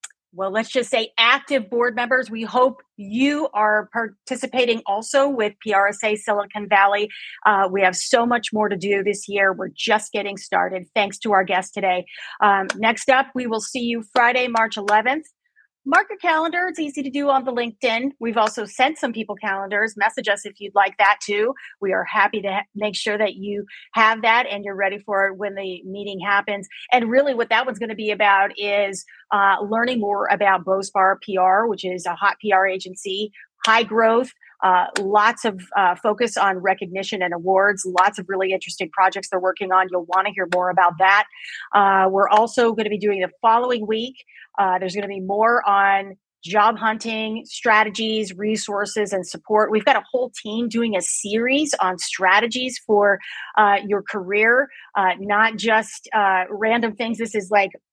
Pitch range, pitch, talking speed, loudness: 195-230 Hz, 210 Hz, 190 wpm, -20 LUFS